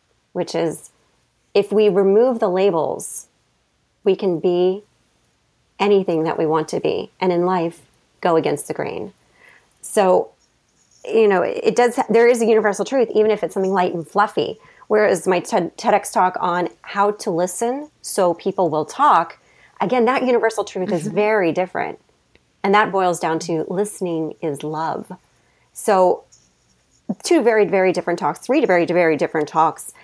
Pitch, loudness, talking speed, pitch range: 195 Hz, -19 LUFS, 155 wpm, 175-215 Hz